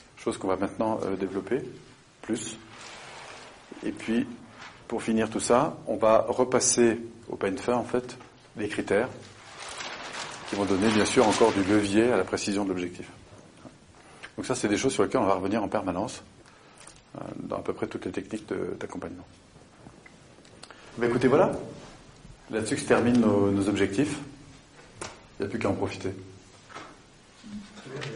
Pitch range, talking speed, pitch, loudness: 100-120 Hz, 160 wpm, 110 Hz, -27 LUFS